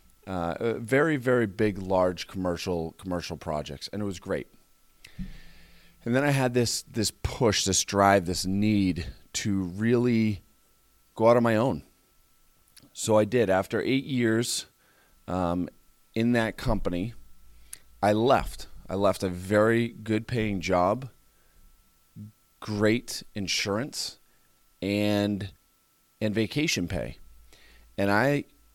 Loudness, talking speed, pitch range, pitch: -27 LUFS, 120 wpm, 90-115 Hz, 100 Hz